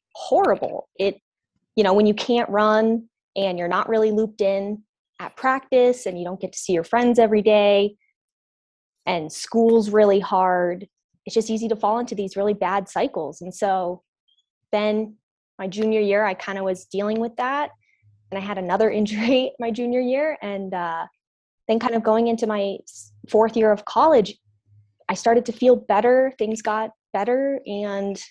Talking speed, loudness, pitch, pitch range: 175 wpm, -21 LUFS, 210 Hz, 195-230 Hz